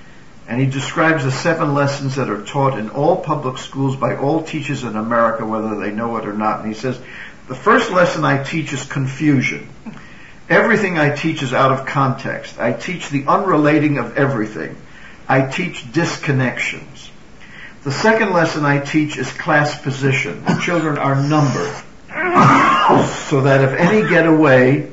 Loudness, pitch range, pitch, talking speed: -16 LUFS, 130-155 Hz, 140 Hz, 165 wpm